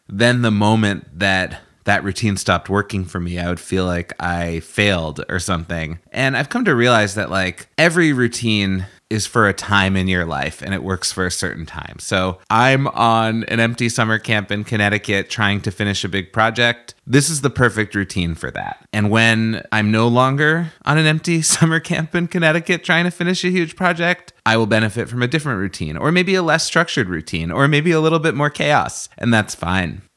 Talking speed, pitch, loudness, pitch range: 205 wpm, 110 Hz, -17 LUFS, 95-140 Hz